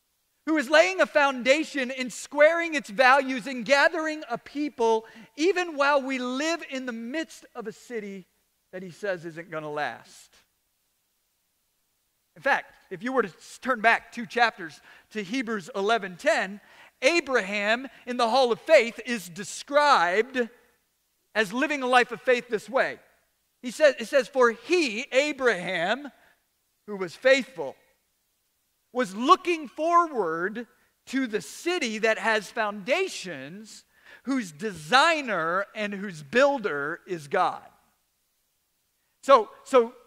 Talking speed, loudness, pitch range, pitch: 130 wpm, -25 LUFS, 215-280 Hz, 245 Hz